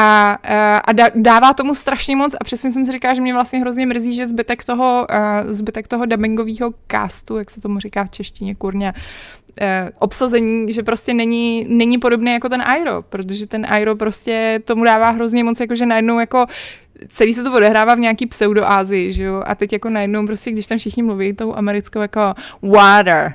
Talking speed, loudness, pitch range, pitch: 190 wpm, -15 LUFS, 210-240 Hz, 225 Hz